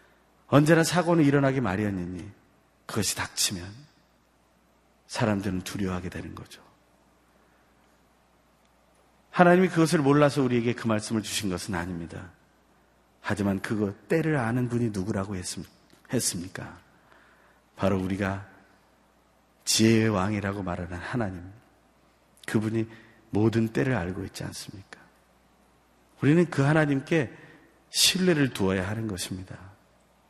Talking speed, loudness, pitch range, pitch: 265 characters per minute, -26 LUFS, 90-125 Hz, 100 Hz